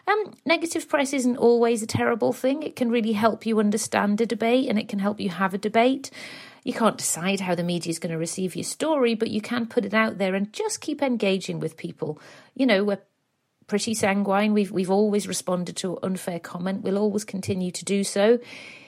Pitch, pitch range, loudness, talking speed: 210 Hz, 185-240 Hz, -24 LUFS, 215 wpm